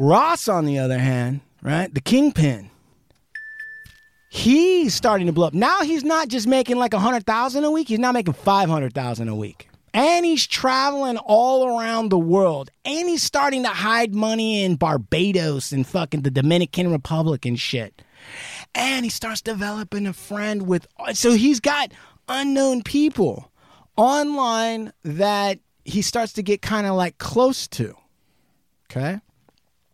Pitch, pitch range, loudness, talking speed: 215 Hz, 160-260 Hz, -20 LUFS, 155 wpm